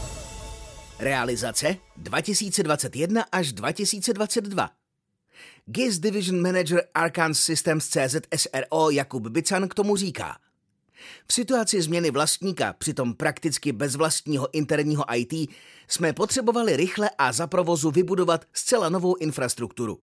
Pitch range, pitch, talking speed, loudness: 145-195 Hz, 165 Hz, 105 wpm, -24 LUFS